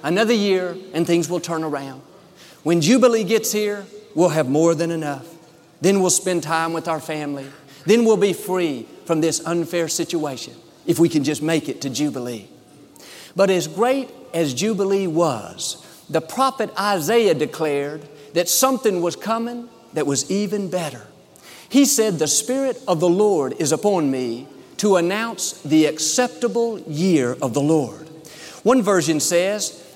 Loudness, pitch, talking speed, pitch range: -20 LUFS, 170 Hz, 155 wpm, 155-205 Hz